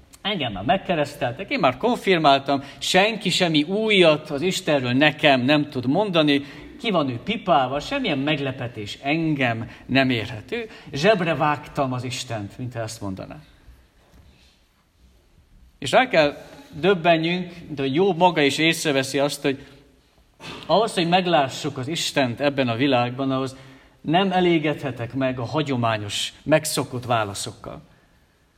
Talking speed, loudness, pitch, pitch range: 120 wpm, -21 LUFS, 140 Hz, 125-160 Hz